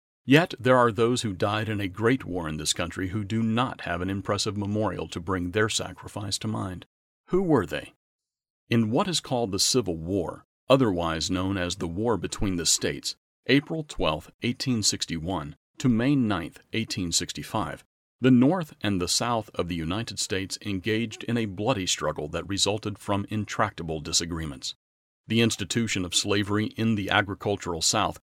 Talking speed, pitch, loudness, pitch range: 175 wpm, 100 Hz, -26 LUFS, 90-115 Hz